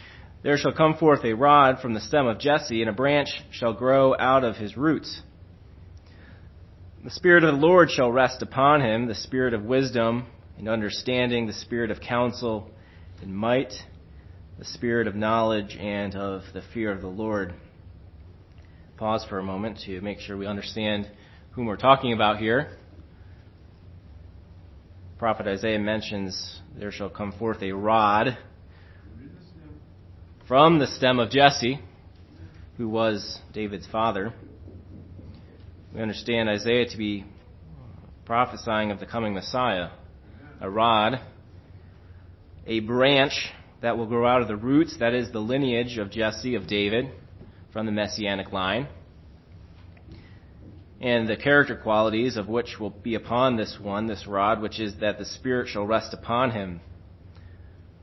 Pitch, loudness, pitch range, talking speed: 105 Hz, -24 LUFS, 90-115 Hz, 145 wpm